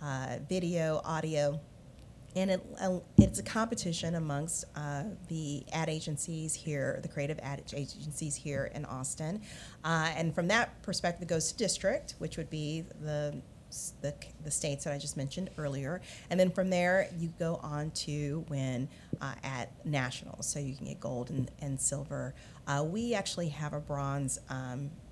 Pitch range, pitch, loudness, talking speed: 140-170 Hz, 150 Hz, -34 LUFS, 165 wpm